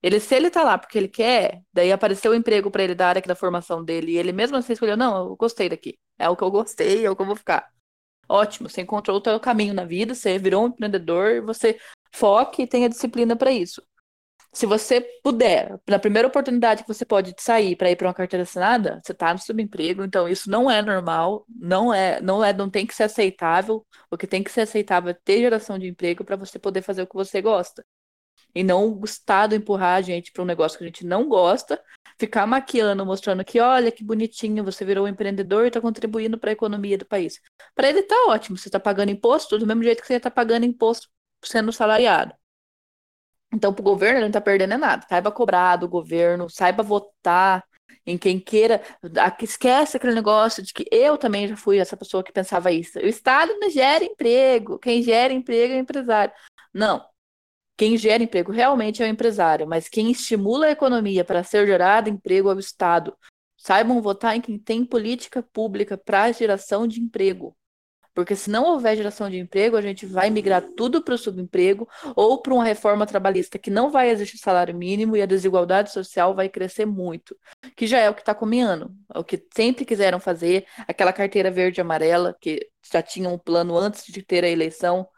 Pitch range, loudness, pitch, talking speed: 190-230 Hz, -21 LUFS, 205 Hz, 210 wpm